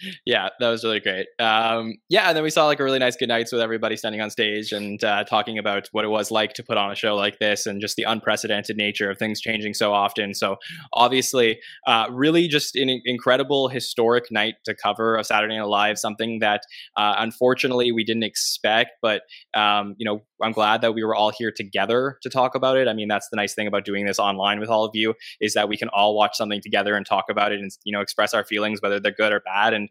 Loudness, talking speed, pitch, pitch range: -22 LUFS, 245 wpm, 110 Hz, 105-120 Hz